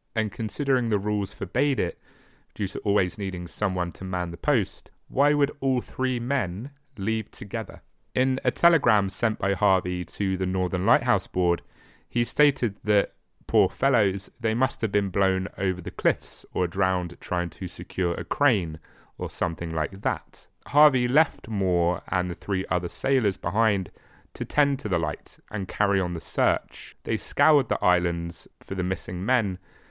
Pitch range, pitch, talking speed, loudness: 90-120 Hz, 100 Hz, 170 wpm, -26 LUFS